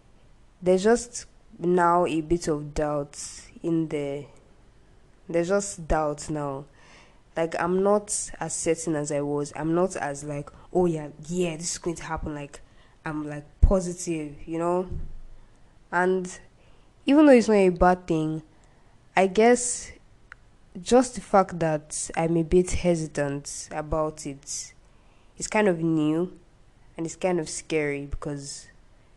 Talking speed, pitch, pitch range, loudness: 140 wpm, 160 Hz, 145-180 Hz, -25 LUFS